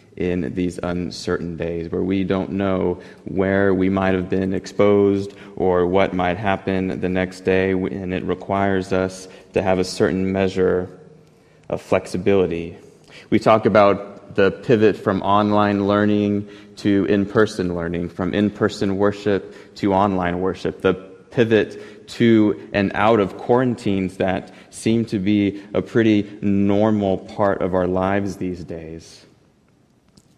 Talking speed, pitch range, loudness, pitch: 140 wpm, 90-100 Hz, -20 LUFS, 95 Hz